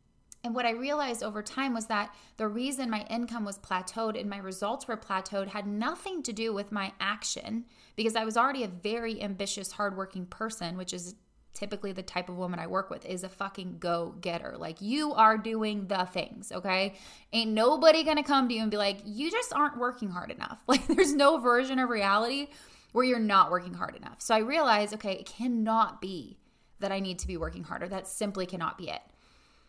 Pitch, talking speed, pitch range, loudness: 215 Hz, 210 wpm, 195-235 Hz, -30 LUFS